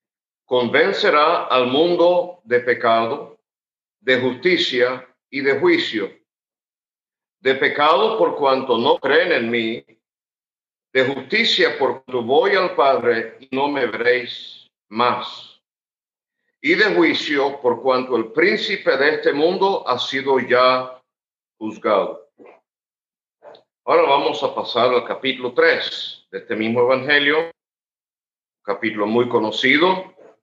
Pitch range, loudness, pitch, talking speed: 125-180 Hz, -18 LUFS, 130 Hz, 110 wpm